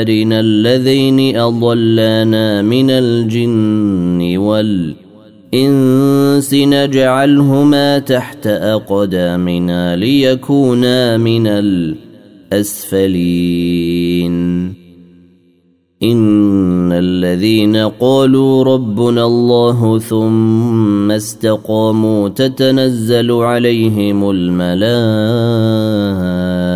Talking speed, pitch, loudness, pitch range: 45 wpm, 110 Hz, -12 LUFS, 95-120 Hz